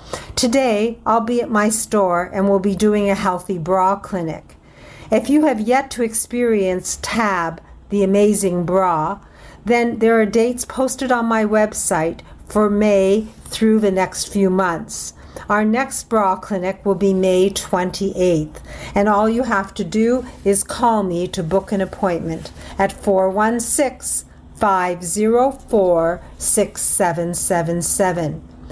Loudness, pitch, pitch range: -18 LUFS, 200 Hz, 185-225 Hz